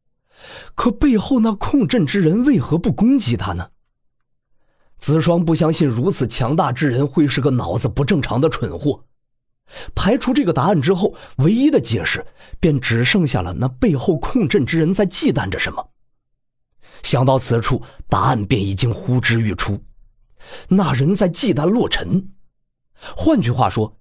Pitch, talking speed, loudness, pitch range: 145 Hz, 230 characters per minute, -17 LUFS, 125-190 Hz